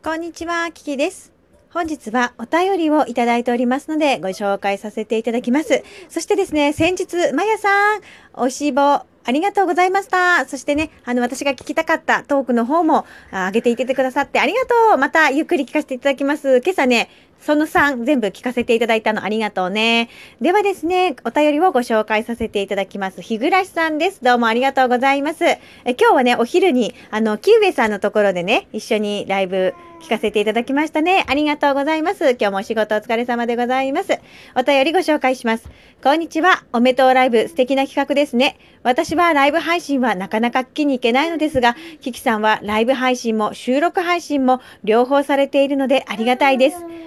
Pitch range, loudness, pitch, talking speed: 235-320 Hz, -17 LUFS, 270 Hz, 420 characters per minute